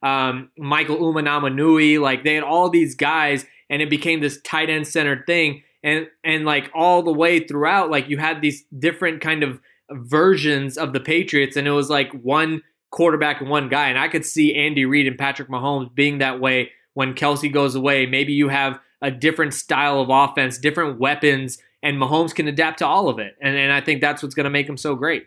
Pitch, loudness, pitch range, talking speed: 145 Hz, -19 LUFS, 140-155 Hz, 215 wpm